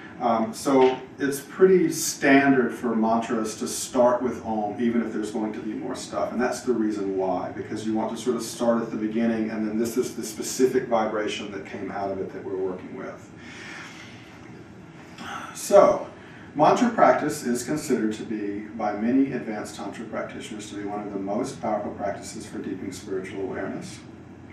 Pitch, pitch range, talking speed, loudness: 115 Hz, 110-125 Hz, 180 wpm, -25 LUFS